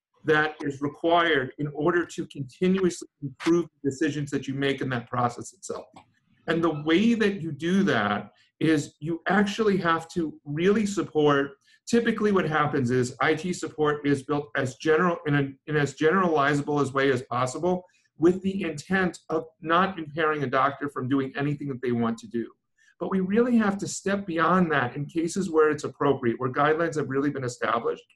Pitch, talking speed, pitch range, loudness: 155 Hz, 180 wpm, 140-175 Hz, -25 LUFS